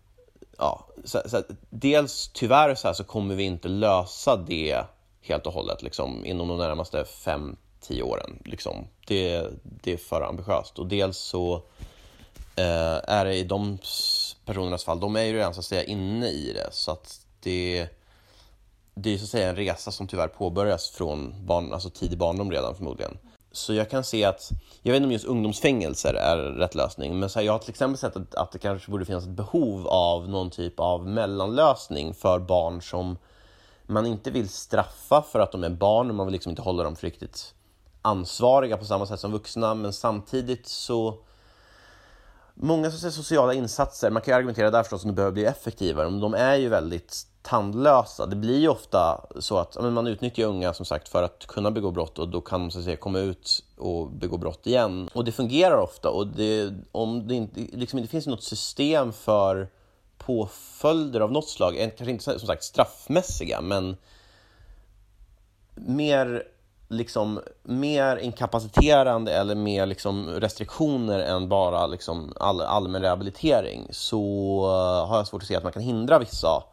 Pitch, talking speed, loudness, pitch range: 100 Hz, 180 wpm, -26 LUFS, 90-115 Hz